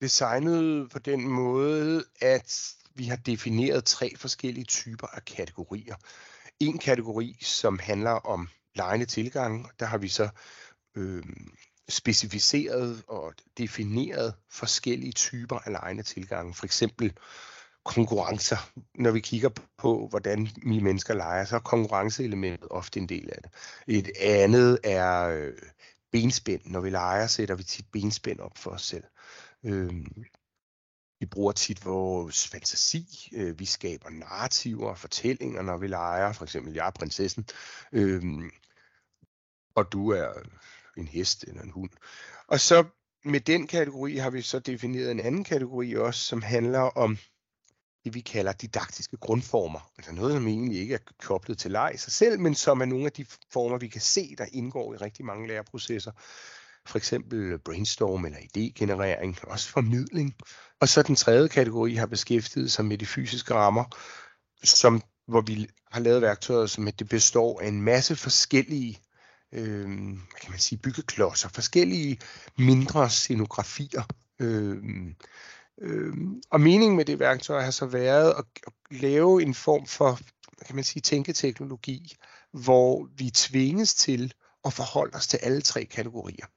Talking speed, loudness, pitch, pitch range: 150 wpm, -26 LUFS, 115 Hz, 105-130 Hz